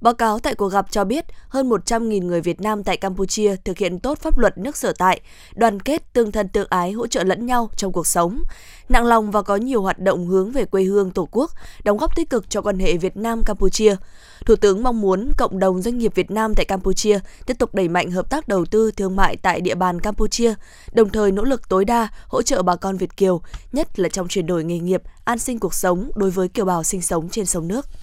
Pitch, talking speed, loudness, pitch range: 205 Hz, 245 wpm, -20 LUFS, 185-230 Hz